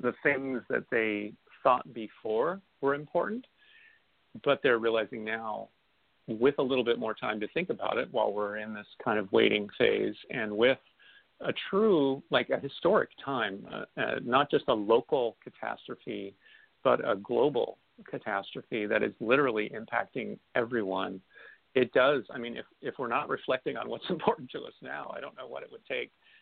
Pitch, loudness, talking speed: 140 Hz, -30 LUFS, 175 wpm